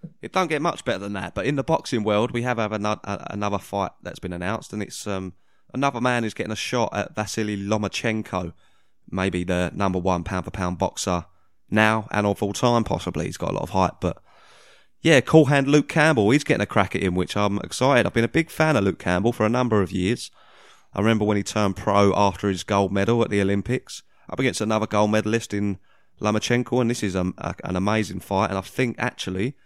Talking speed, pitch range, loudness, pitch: 225 wpm, 95-120 Hz, -23 LUFS, 105 Hz